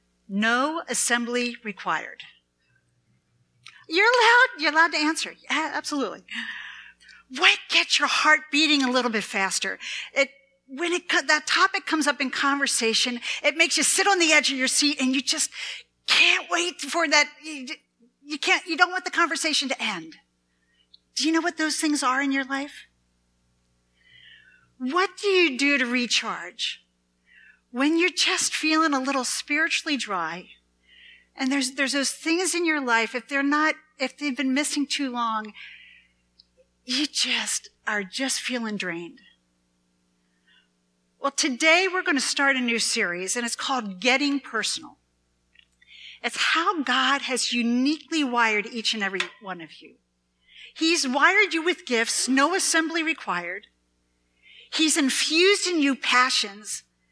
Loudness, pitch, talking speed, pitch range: -22 LUFS, 270 Hz, 150 wpm, 210-310 Hz